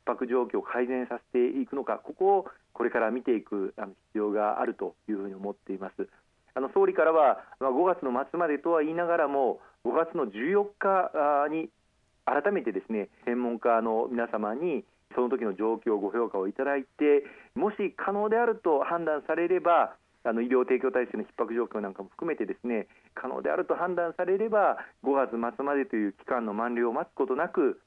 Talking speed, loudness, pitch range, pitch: 365 characters per minute, -29 LUFS, 115-170 Hz, 130 Hz